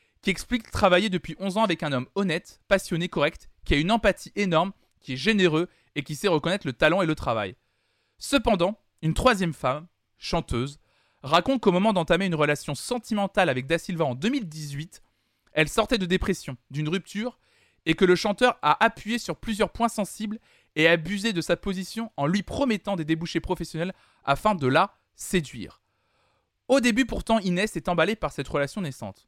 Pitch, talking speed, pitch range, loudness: 175 Hz, 180 wpm, 150-210 Hz, -25 LUFS